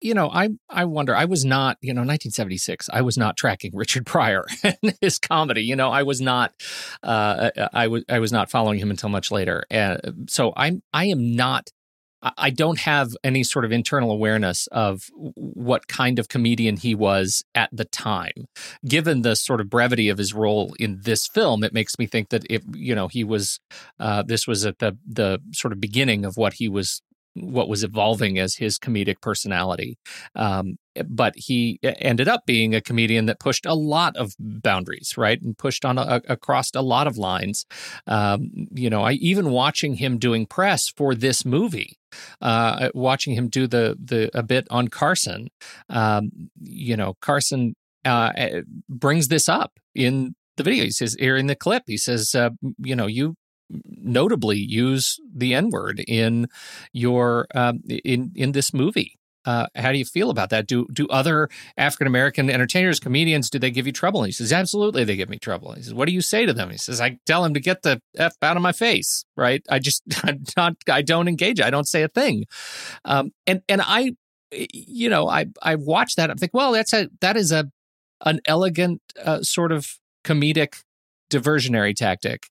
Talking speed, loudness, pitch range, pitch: 200 wpm, -21 LUFS, 110-155 Hz, 125 Hz